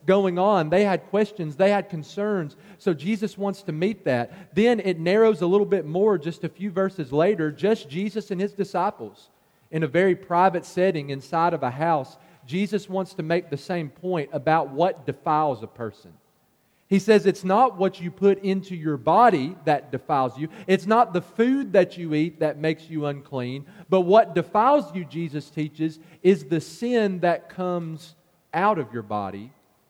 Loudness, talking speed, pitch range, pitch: -23 LUFS, 185 wpm, 155-195 Hz, 175 Hz